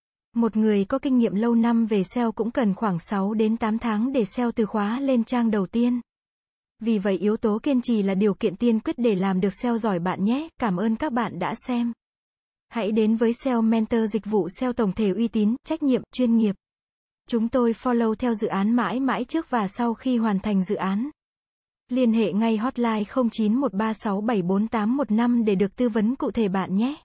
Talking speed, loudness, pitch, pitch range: 205 wpm, -24 LUFS, 225 Hz, 210-245 Hz